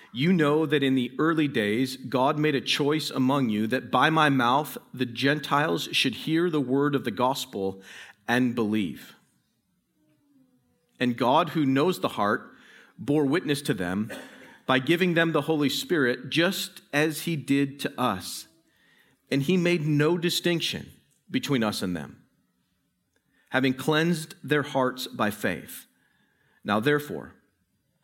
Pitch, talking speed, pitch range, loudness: 140 Hz, 145 wpm, 130-155 Hz, -25 LUFS